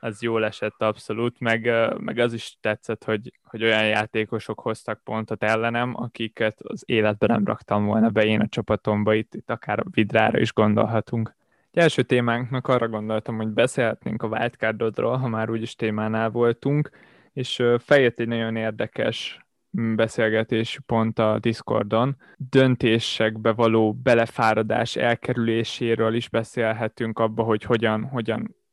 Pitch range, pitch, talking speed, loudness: 110-120 Hz, 115 Hz, 140 wpm, -23 LUFS